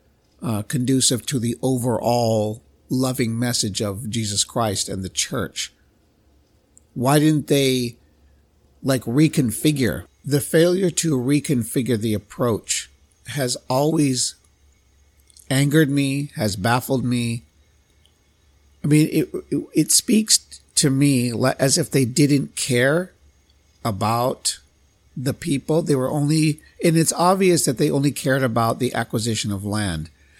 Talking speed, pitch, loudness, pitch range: 120 wpm, 125 Hz, -20 LUFS, 100-145 Hz